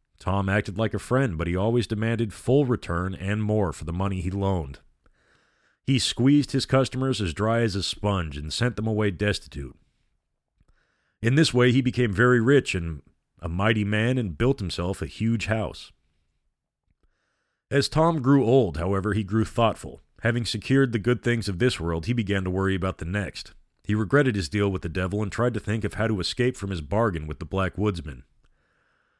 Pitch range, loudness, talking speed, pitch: 90-120 Hz, -25 LUFS, 195 wpm, 105 Hz